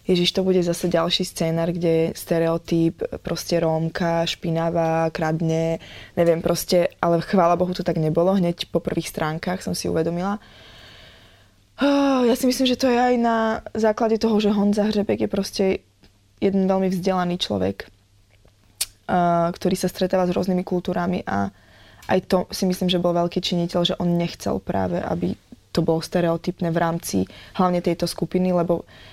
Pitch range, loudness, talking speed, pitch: 165-185 Hz, -22 LUFS, 160 wpm, 175 Hz